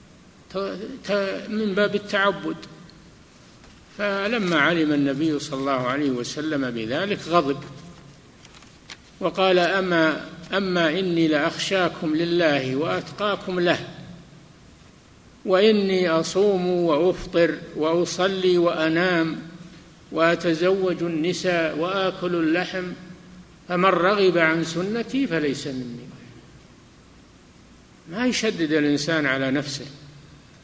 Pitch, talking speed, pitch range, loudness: 170 Hz, 80 wpm, 155-185 Hz, -22 LUFS